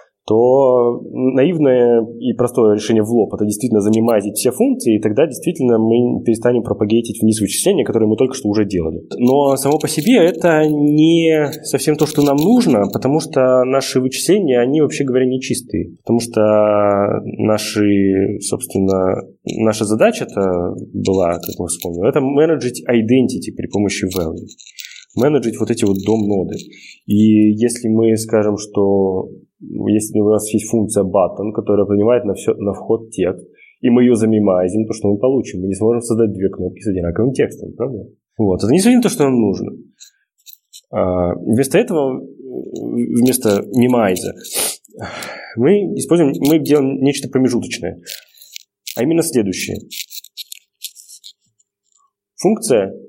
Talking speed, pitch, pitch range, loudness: 145 wpm, 110 Hz, 105-130 Hz, -15 LUFS